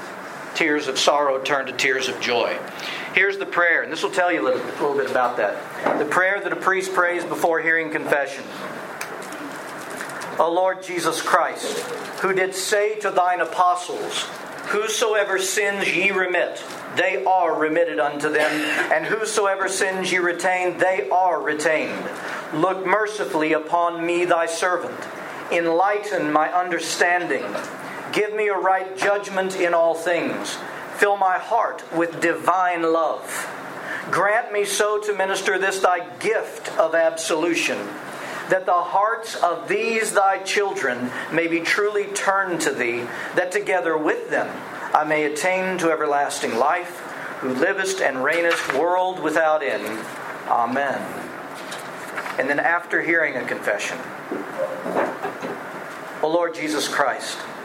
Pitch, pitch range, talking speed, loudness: 180 Hz, 165-195 Hz, 140 wpm, -21 LUFS